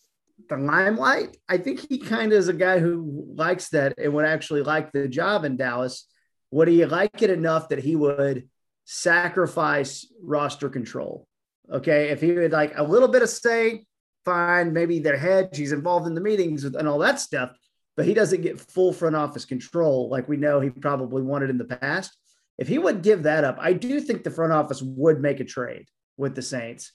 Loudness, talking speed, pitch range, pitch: -23 LUFS, 205 wpm, 140-180 Hz, 155 Hz